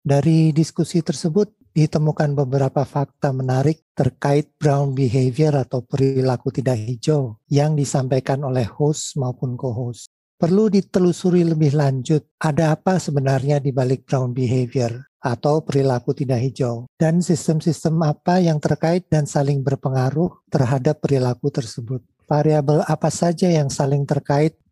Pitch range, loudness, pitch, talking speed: 135-160 Hz, -20 LUFS, 145 Hz, 125 wpm